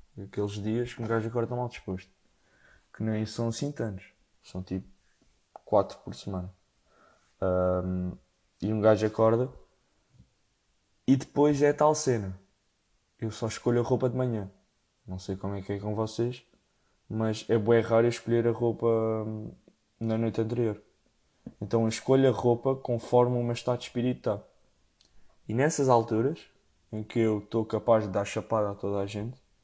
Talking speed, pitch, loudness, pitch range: 160 wpm, 110 Hz, -29 LUFS, 100-120 Hz